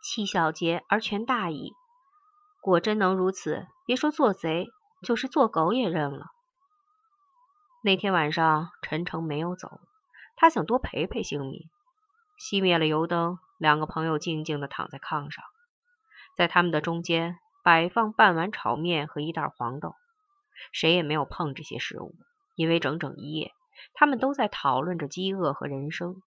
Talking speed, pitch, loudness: 225 characters per minute, 180 Hz, -26 LUFS